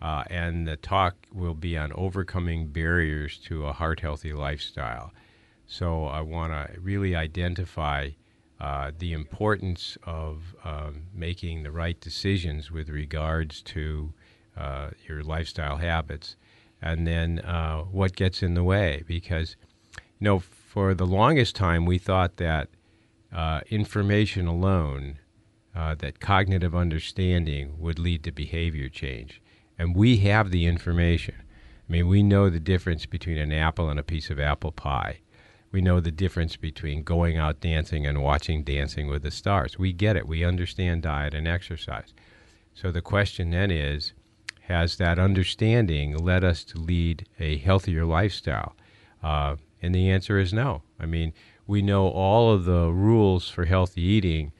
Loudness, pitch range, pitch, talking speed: -26 LUFS, 80-95 Hz, 85 Hz, 155 wpm